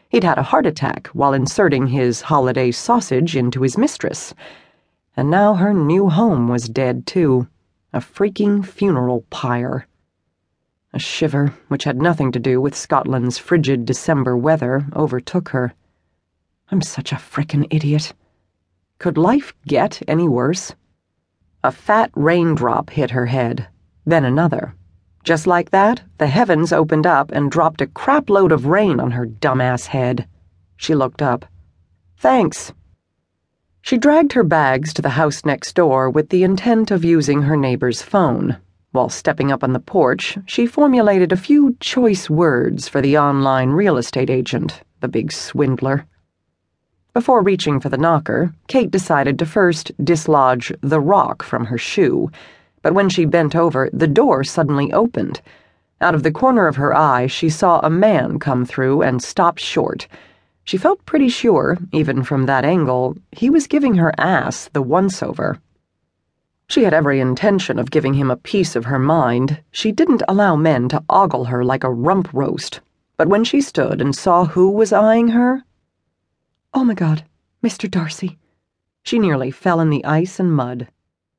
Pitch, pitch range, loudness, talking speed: 150 Hz, 125-185 Hz, -17 LUFS, 160 wpm